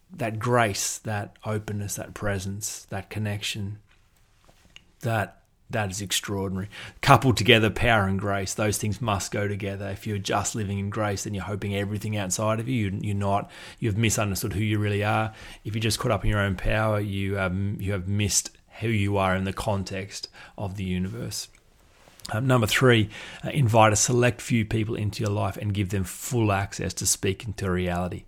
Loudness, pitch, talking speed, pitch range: -26 LUFS, 105 Hz, 185 wpm, 100-110 Hz